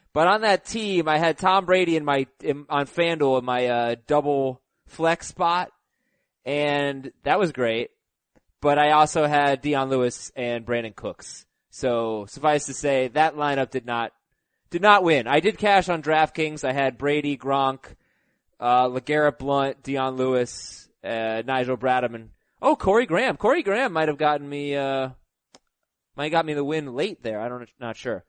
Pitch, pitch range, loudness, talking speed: 140 Hz, 125-155 Hz, -23 LUFS, 175 wpm